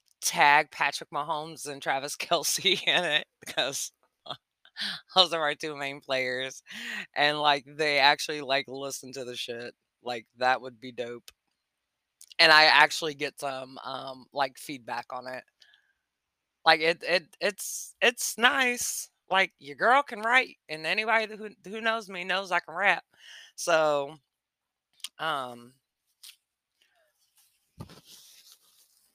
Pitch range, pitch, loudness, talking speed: 130-190 Hz, 150 Hz, -26 LUFS, 130 wpm